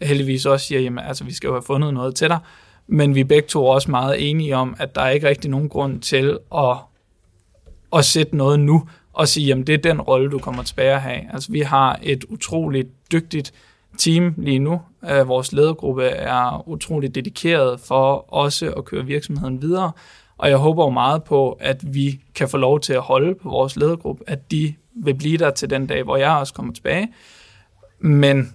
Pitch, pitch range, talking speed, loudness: 140 Hz, 130-155 Hz, 205 wpm, -19 LUFS